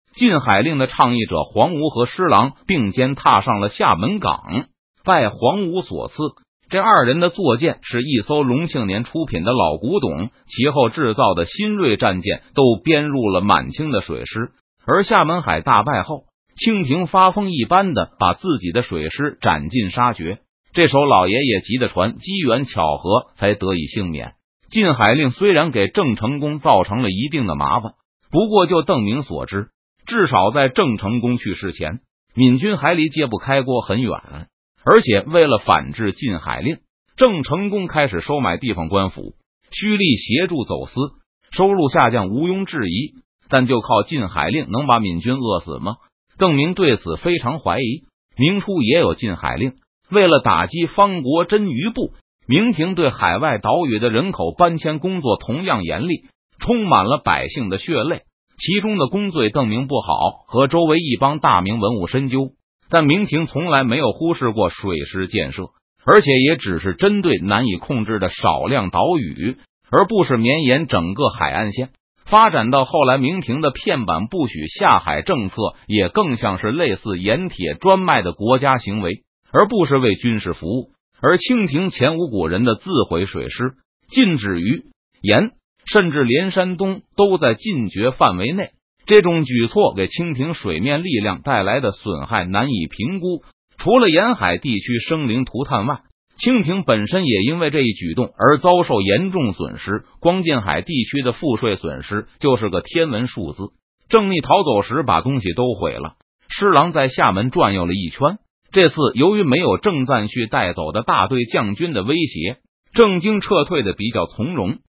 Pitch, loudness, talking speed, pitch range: 135 Hz, -17 LUFS, 255 characters per minute, 110-175 Hz